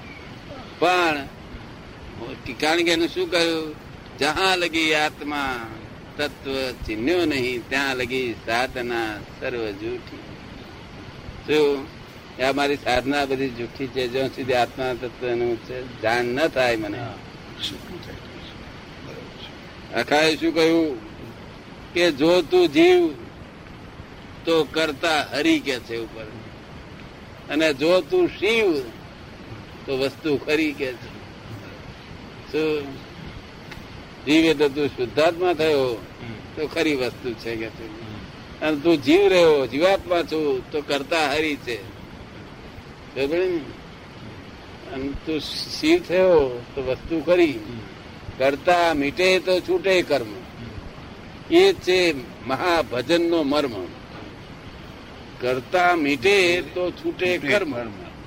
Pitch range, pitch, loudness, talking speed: 130-175 Hz, 150 Hz, -22 LUFS, 75 wpm